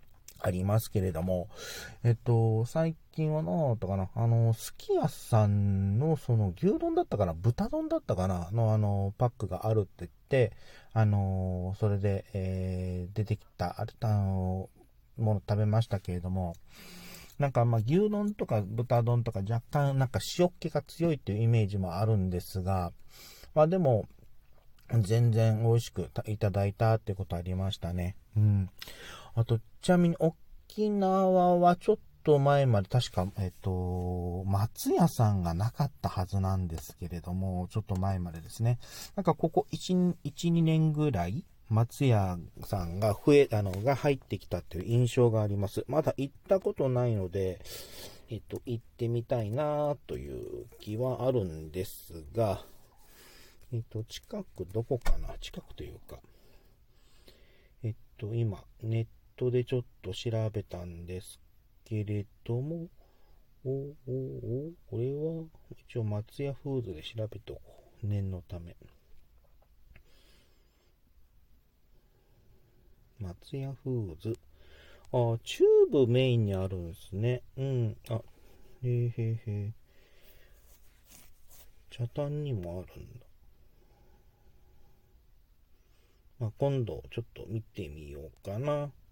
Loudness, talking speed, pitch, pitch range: -31 LUFS, 255 characters per minute, 110 Hz, 95-125 Hz